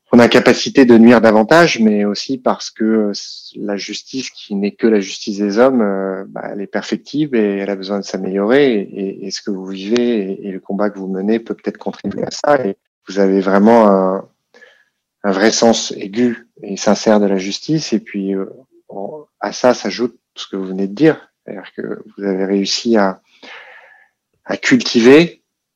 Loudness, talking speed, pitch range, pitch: -15 LUFS, 180 wpm, 100-115 Hz, 105 Hz